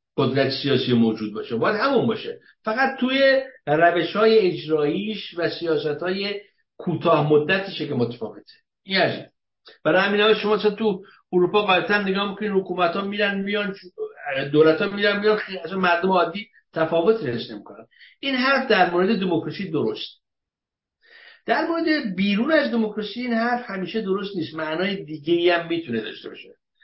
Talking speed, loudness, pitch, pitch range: 150 wpm, -22 LUFS, 200 Hz, 170-225 Hz